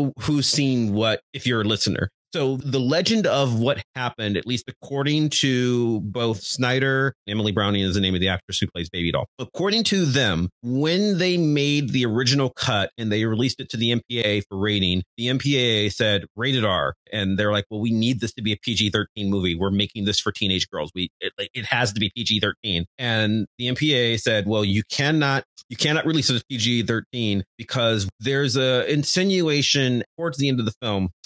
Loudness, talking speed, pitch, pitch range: -22 LUFS, 195 wpm, 115 Hz, 105-135 Hz